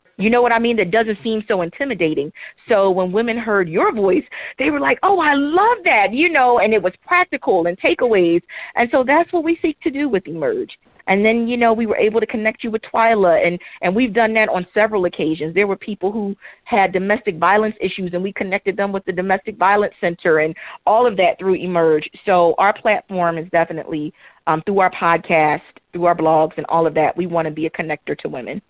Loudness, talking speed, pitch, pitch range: -17 LUFS, 225 wpm, 200 Hz, 175-230 Hz